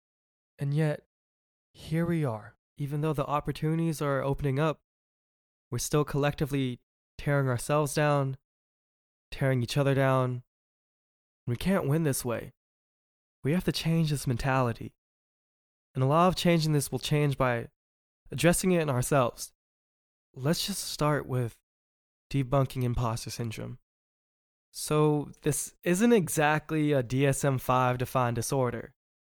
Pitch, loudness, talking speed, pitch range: 135 Hz, -28 LUFS, 130 wpm, 120-150 Hz